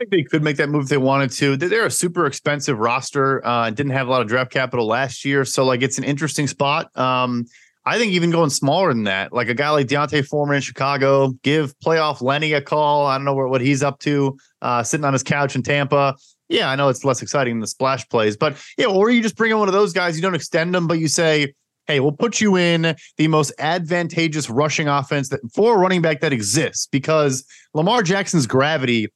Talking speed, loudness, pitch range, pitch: 245 wpm, -19 LUFS, 135-160 Hz, 145 Hz